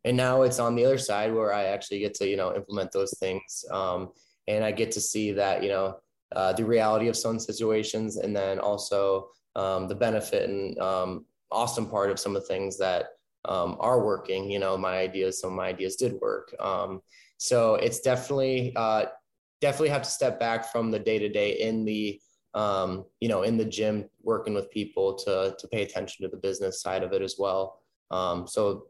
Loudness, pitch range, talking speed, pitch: -28 LUFS, 95-115 Hz, 210 wpm, 105 Hz